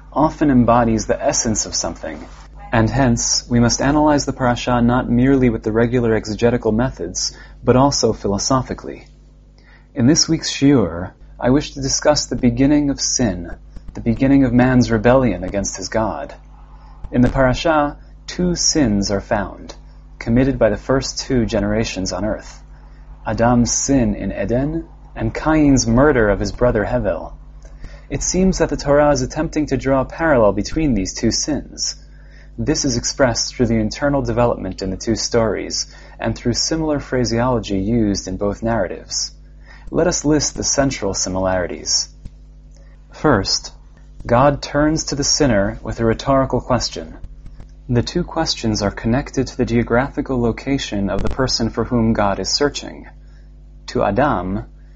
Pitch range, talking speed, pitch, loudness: 110-140 Hz, 150 wpm, 120 Hz, -17 LUFS